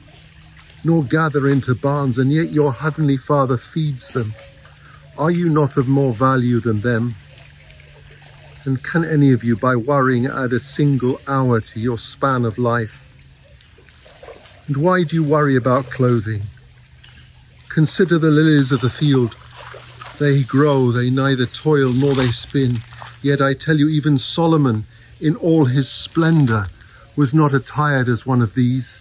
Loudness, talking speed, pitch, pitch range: -17 LUFS, 150 wpm, 135 Hz, 120-145 Hz